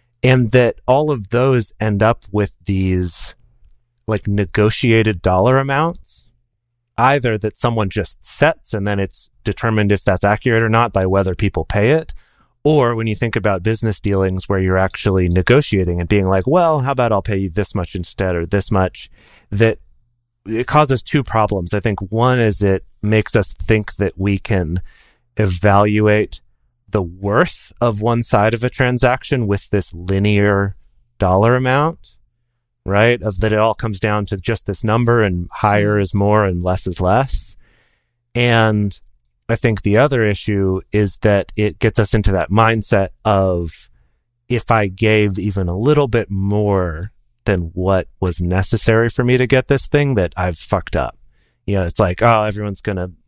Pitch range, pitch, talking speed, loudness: 95-115 Hz, 105 Hz, 170 wpm, -17 LUFS